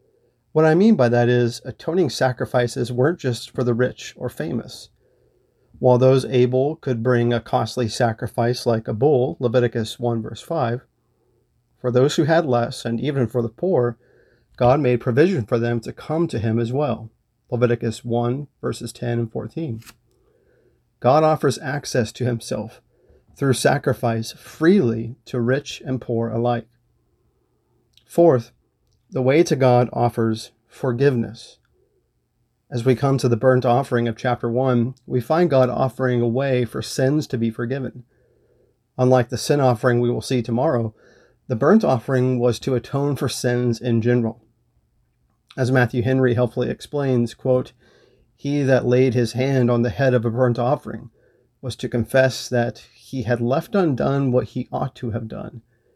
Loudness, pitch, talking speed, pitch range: -20 LUFS, 125 Hz, 160 wpm, 120-130 Hz